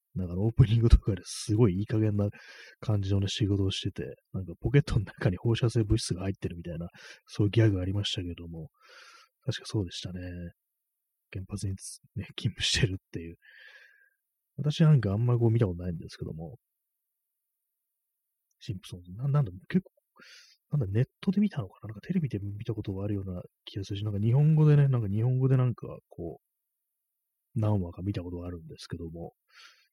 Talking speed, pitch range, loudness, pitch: 385 characters per minute, 95-130 Hz, -29 LUFS, 105 Hz